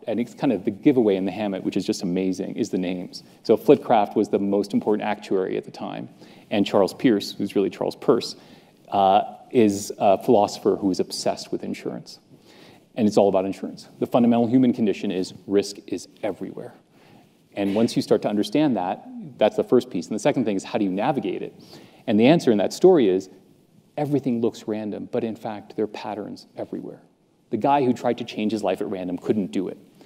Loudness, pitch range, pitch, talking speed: -23 LUFS, 100-125 Hz, 110 Hz, 210 wpm